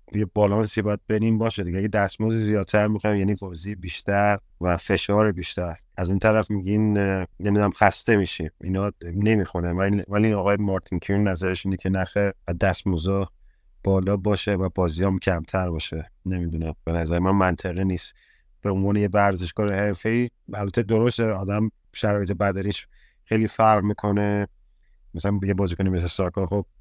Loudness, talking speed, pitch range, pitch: -24 LUFS, 150 wpm, 95-105 Hz, 100 Hz